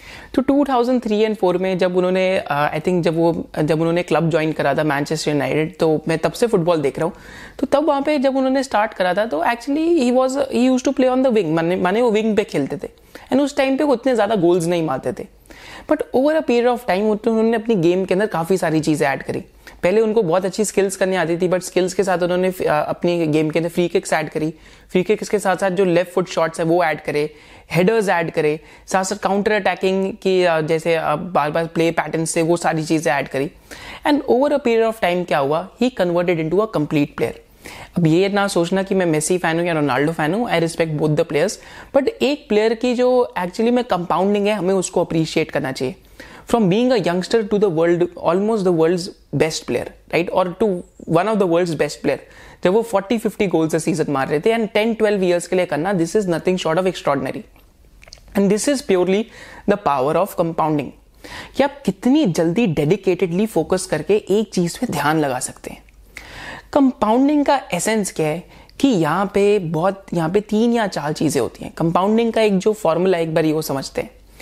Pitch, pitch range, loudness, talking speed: 185 Hz, 165-220 Hz, -18 LUFS, 220 wpm